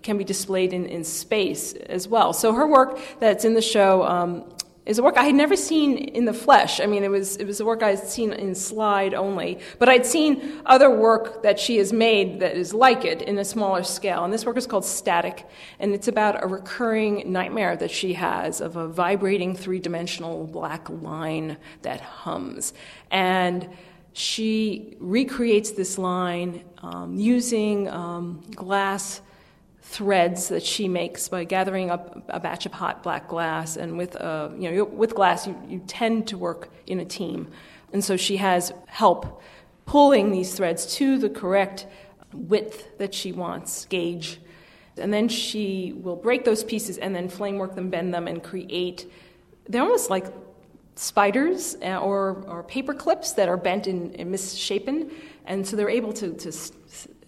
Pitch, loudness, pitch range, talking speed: 195 Hz, -23 LUFS, 180-220 Hz, 180 wpm